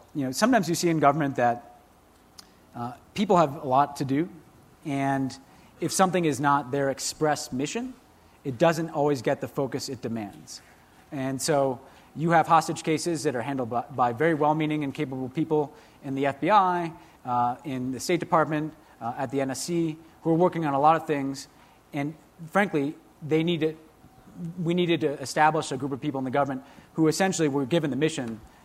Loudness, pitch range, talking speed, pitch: -26 LUFS, 135-160 Hz, 180 wpm, 145 Hz